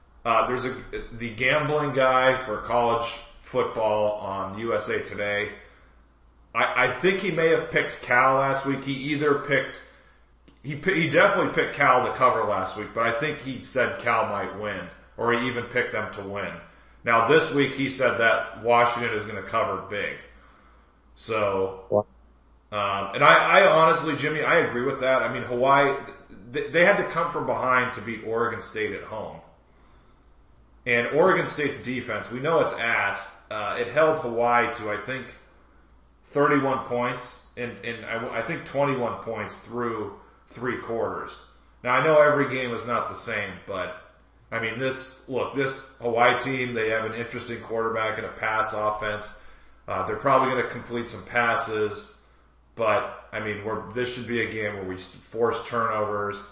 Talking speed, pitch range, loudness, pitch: 170 wpm, 105-130 Hz, -24 LUFS, 115 Hz